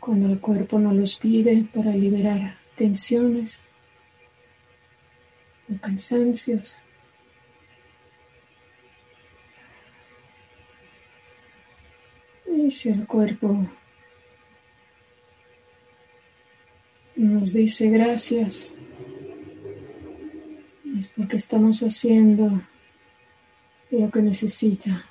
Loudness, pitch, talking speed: -22 LUFS, 185 Hz, 60 wpm